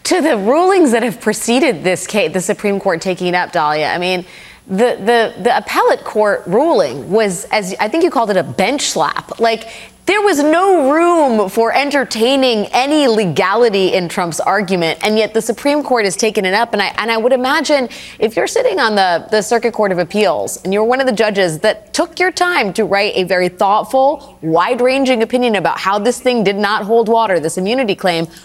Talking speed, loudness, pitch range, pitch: 210 wpm, -14 LUFS, 195-255 Hz, 220 Hz